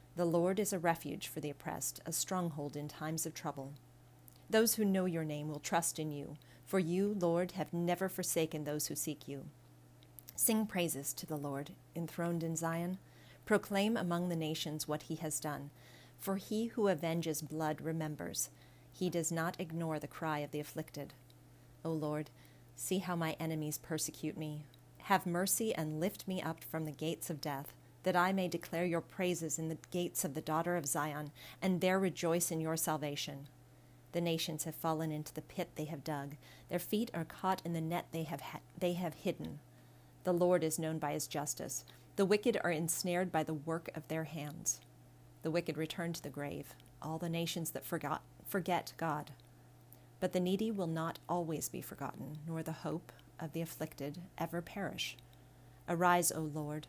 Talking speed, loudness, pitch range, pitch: 185 wpm, -38 LUFS, 145-175 Hz, 160 Hz